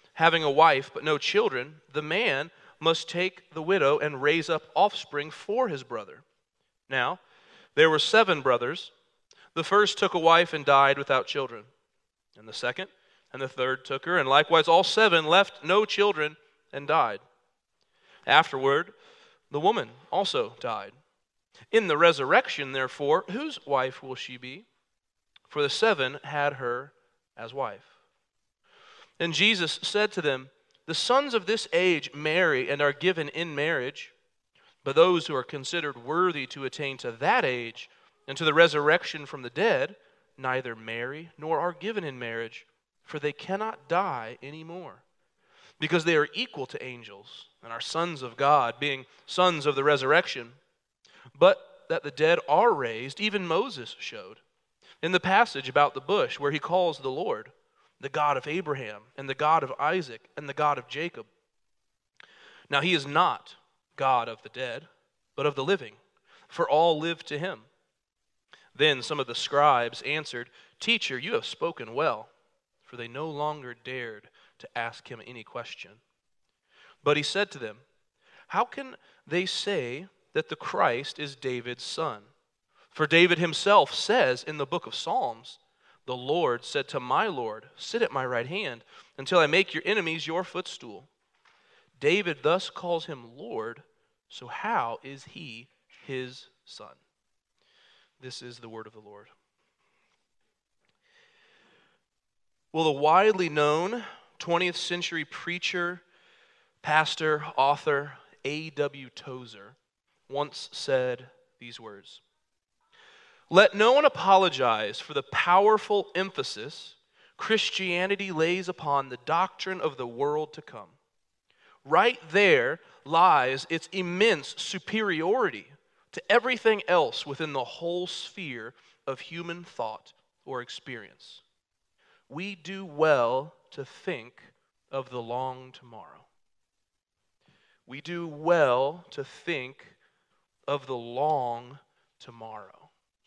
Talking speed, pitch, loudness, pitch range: 140 wpm, 155 Hz, -26 LUFS, 135-190 Hz